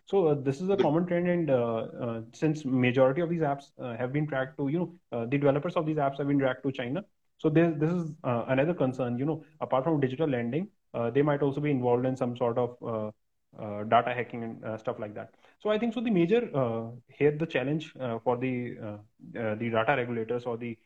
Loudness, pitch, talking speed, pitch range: -29 LUFS, 130 Hz, 245 wpm, 120-155 Hz